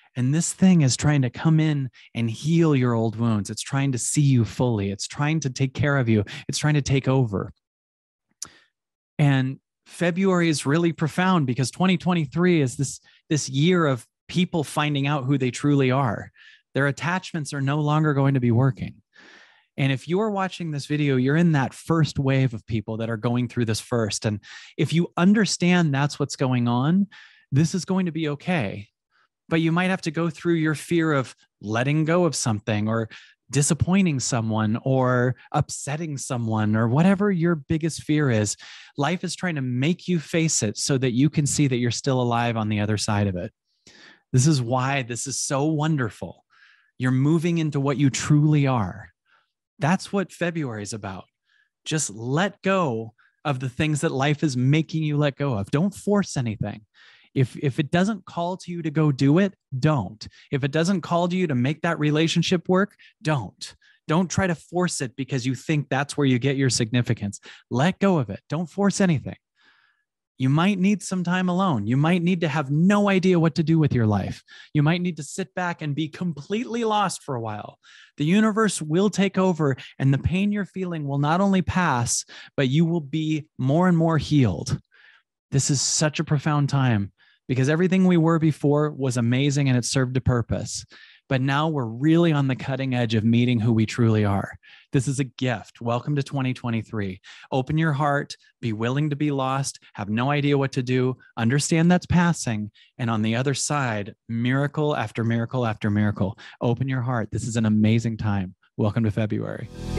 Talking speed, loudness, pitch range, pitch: 195 wpm, -23 LUFS, 120-165 Hz, 140 Hz